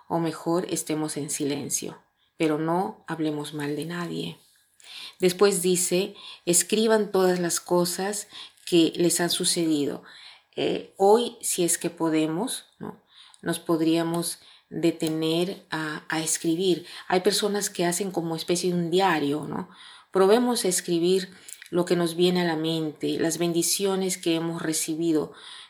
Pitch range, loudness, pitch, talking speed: 160-185 Hz, -25 LUFS, 170 Hz, 140 wpm